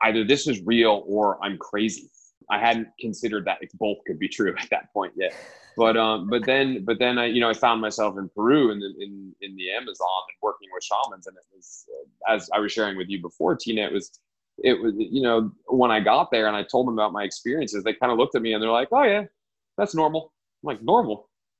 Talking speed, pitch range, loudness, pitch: 245 wpm, 105-130 Hz, -23 LUFS, 115 Hz